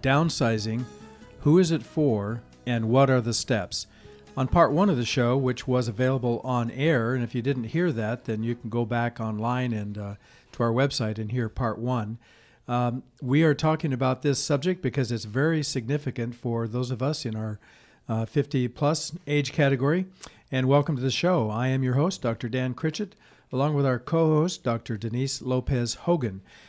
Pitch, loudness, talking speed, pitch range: 130 Hz, -26 LUFS, 190 wpm, 115-145 Hz